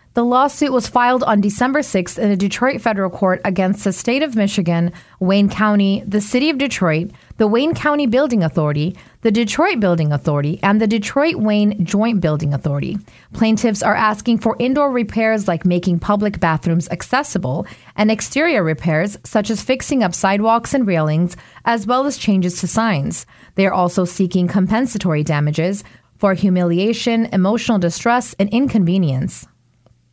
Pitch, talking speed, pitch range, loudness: 205 Hz, 155 wpm, 180-235 Hz, -17 LUFS